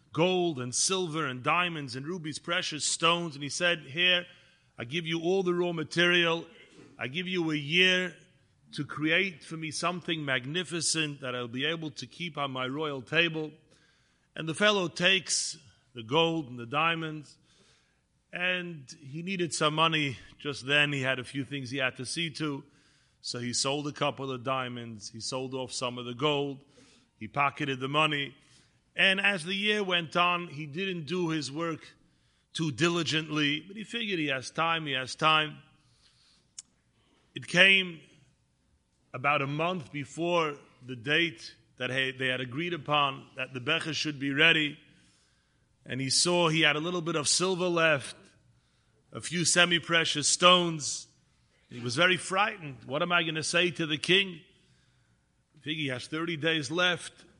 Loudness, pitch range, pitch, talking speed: -28 LUFS, 135-170 Hz, 155 Hz, 170 wpm